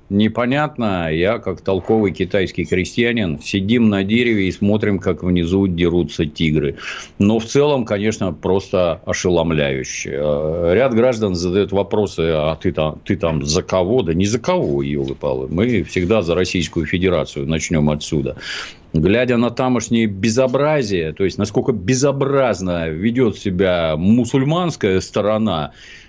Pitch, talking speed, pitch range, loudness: 95 Hz, 130 wpm, 85-115 Hz, -18 LUFS